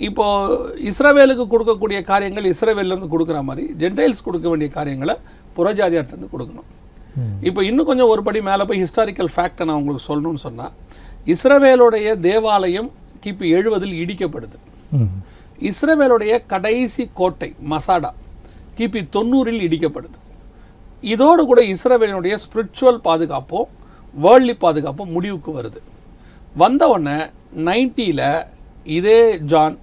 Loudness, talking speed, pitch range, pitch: -17 LUFS, 105 wpm, 150-225 Hz, 185 Hz